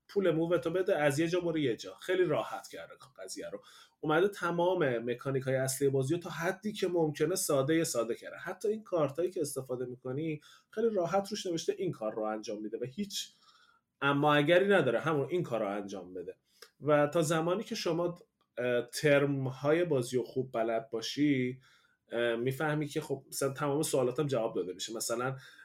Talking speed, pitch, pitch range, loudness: 185 wpm, 155 Hz, 130-180 Hz, -32 LUFS